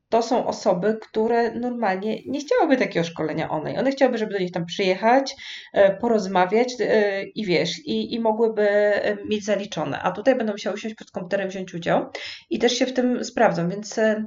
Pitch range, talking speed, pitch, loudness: 195-235 Hz, 170 wpm, 215 Hz, -22 LUFS